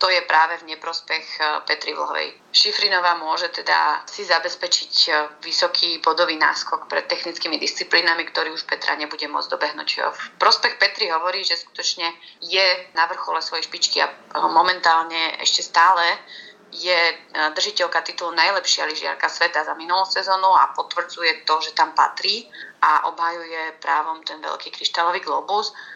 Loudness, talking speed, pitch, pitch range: -20 LUFS, 140 wpm, 170 Hz, 160-180 Hz